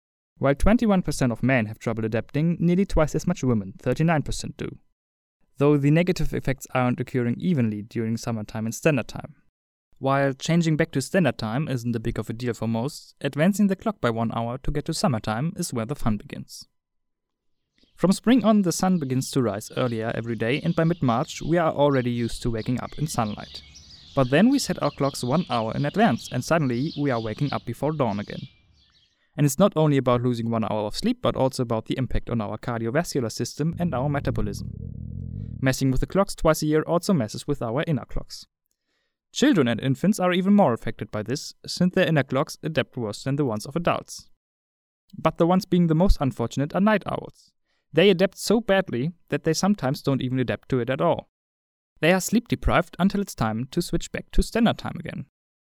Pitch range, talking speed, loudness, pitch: 115-165 Hz, 205 wpm, -24 LUFS, 135 Hz